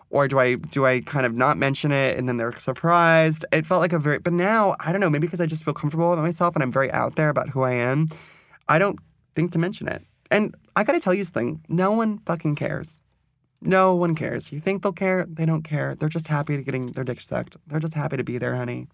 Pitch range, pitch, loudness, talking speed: 135-175 Hz, 155 Hz, -23 LUFS, 265 wpm